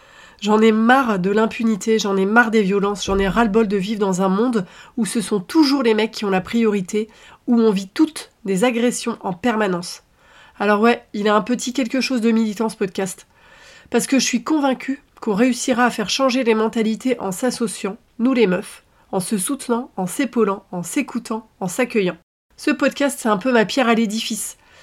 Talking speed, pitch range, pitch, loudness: 210 wpm, 205-245 Hz, 225 Hz, -19 LUFS